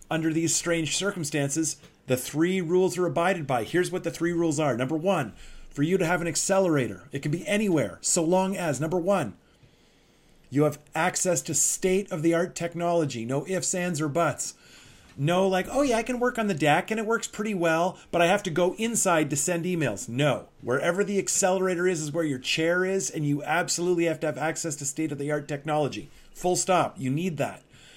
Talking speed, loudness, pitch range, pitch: 210 wpm, -26 LUFS, 150-185 Hz, 170 Hz